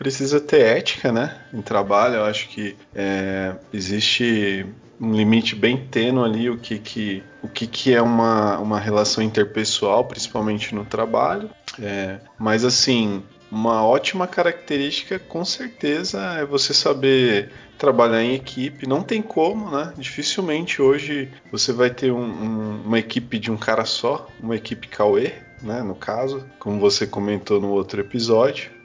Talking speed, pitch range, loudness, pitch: 150 wpm, 105-135 Hz, -21 LUFS, 115 Hz